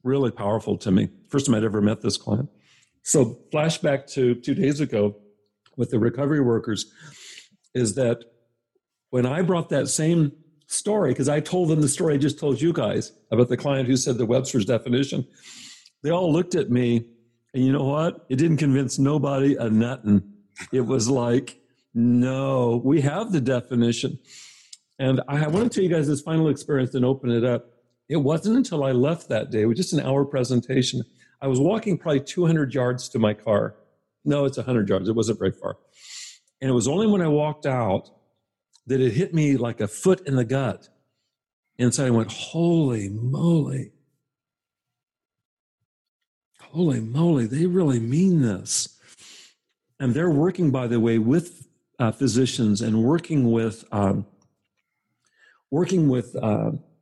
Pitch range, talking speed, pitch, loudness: 120-150 Hz, 170 wpm, 135 Hz, -23 LUFS